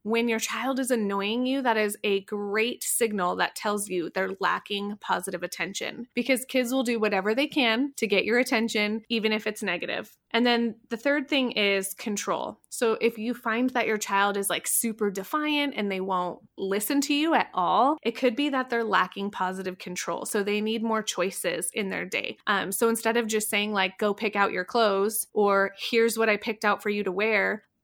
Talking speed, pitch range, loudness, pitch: 210 wpm, 200-235 Hz, -26 LUFS, 220 Hz